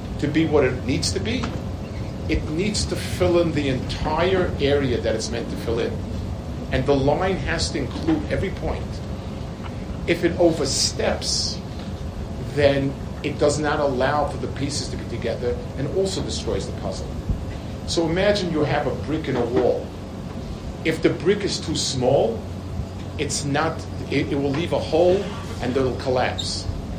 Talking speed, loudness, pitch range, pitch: 165 wpm, -23 LUFS, 95-145 Hz, 125 Hz